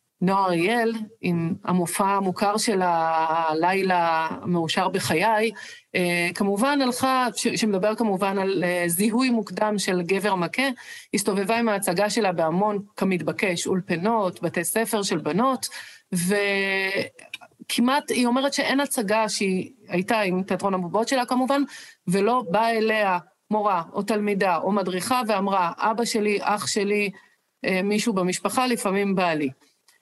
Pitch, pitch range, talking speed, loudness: 205 Hz, 185-230 Hz, 120 wpm, -23 LUFS